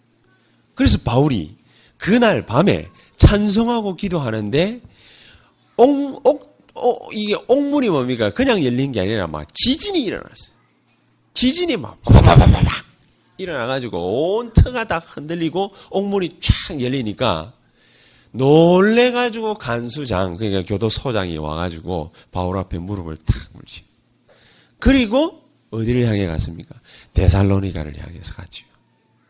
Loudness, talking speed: -18 LUFS, 270 characters per minute